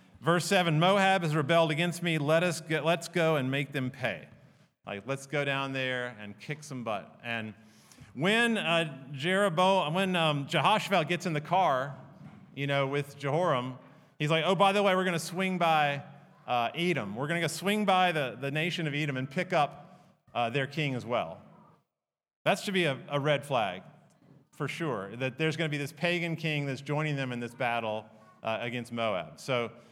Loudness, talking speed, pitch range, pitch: -29 LUFS, 195 wpm, 135-175 Hz, 155 Hz